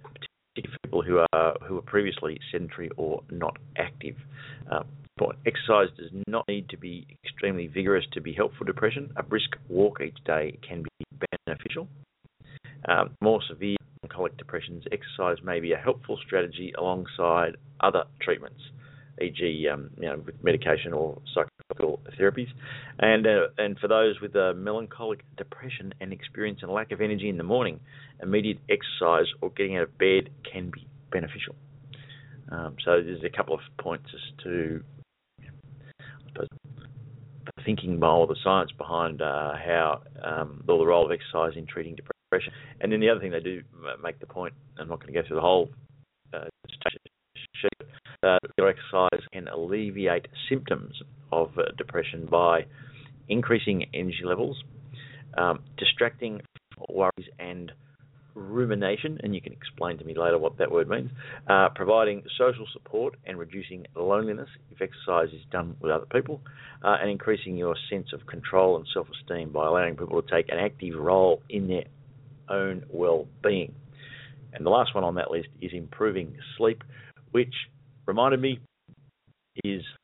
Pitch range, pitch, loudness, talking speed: 100-140 Hz, 125 Hz, -27 LUFS, 155 wpm